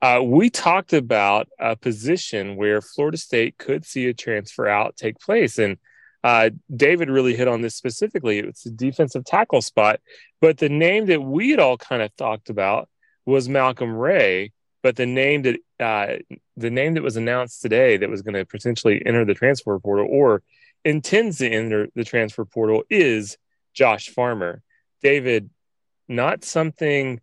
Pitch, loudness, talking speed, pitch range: 125 Hz, -20 LUFS, 165 wpm, 115-155 Hz